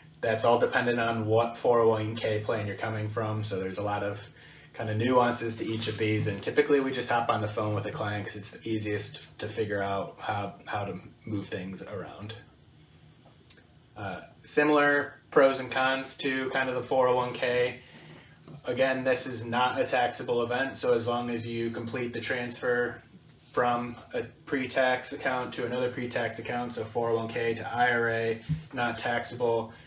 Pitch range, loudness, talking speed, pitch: 110-125 Hz, -29 LUFS, 175 wpm, 120 Hz